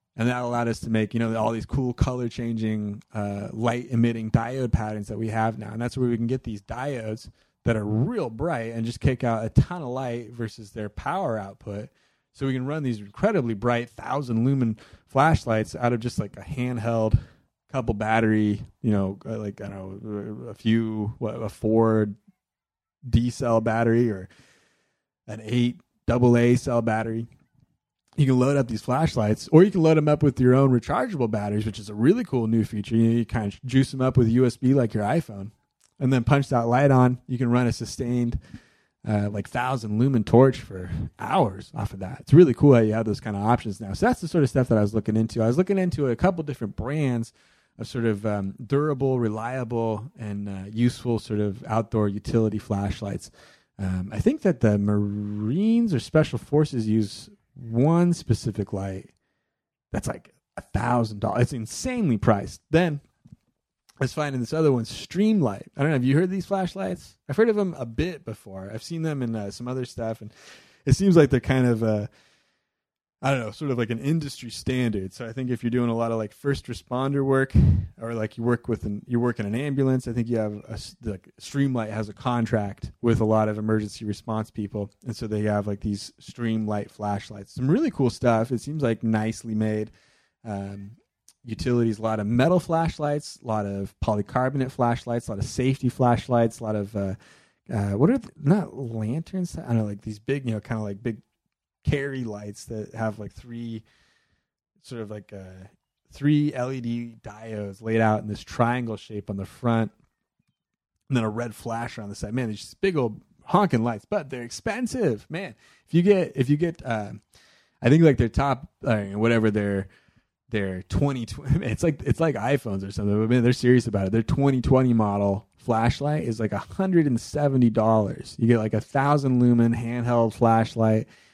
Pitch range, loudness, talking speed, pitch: 110-130 Hz, -24 LUFS, 200 wpm, 115 Hz